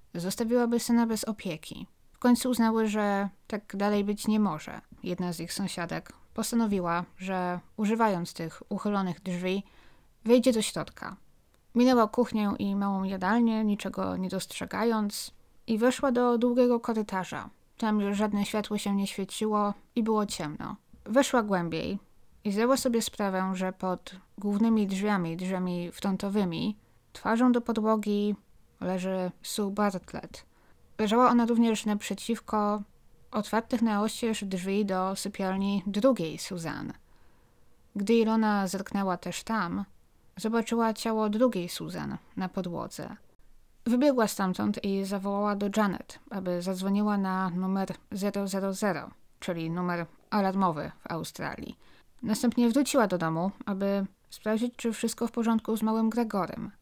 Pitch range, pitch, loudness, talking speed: 190-225 Hz, 205 Hz, -29 LUFS, 125 wpm